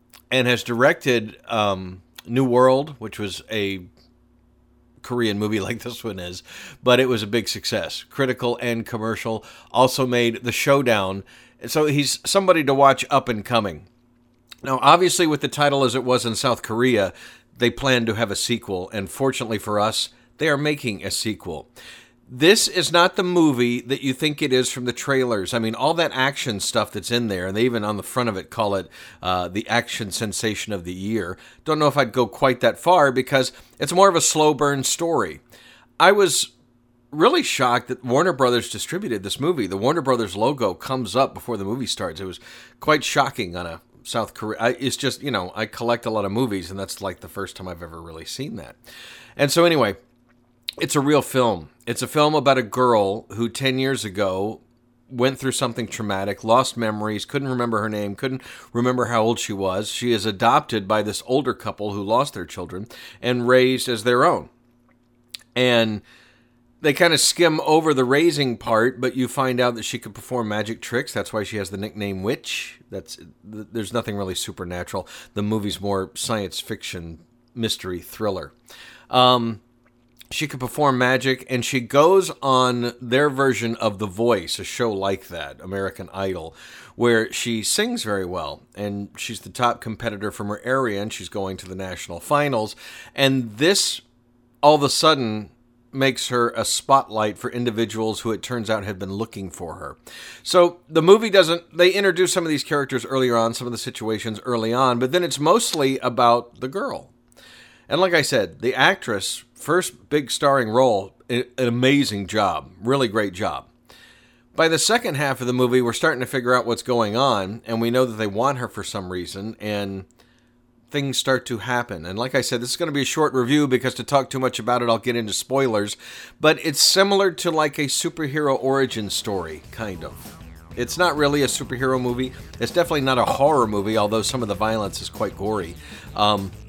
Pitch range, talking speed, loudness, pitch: 105-130 Hz, 195 wpm, -21 LUFS, 120 Hz